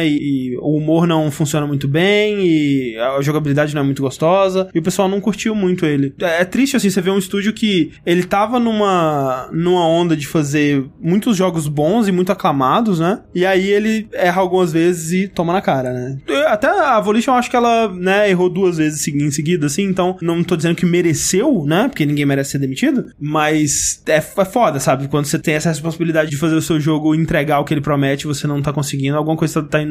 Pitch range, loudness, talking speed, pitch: 150-190 Hz, -16 LUFS, 220 wpm, 165 Hz